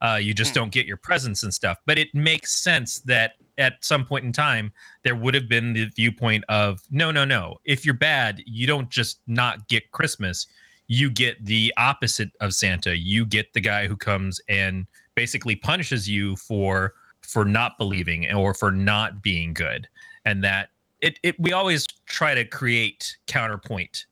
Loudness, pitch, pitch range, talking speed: -22 LUFS, 115 Hz, 105-140 Hz, 180 wpm